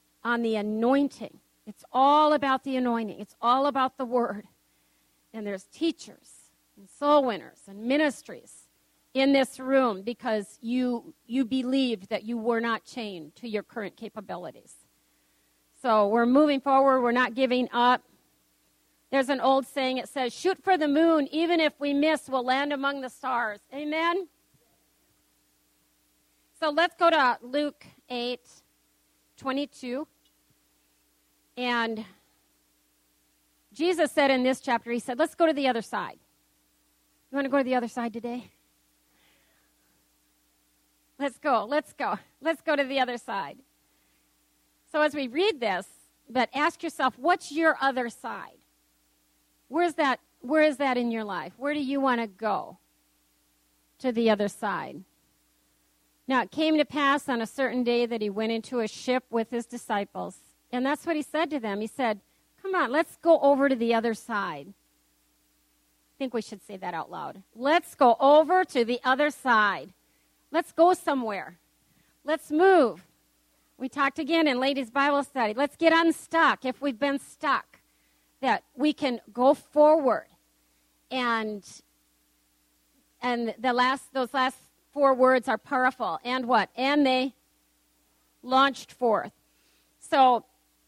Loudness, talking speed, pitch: -26 LUFS, 150 wpm, 245 Hz